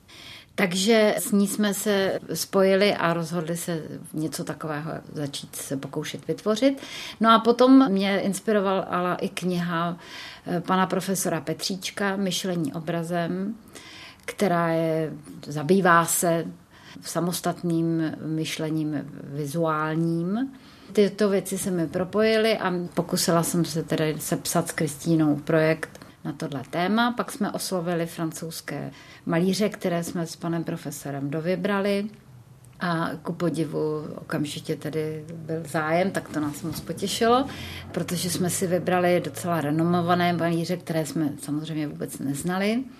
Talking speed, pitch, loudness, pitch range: 120 wpm, 170 Hz, -25 LUFS, 160-190 Hz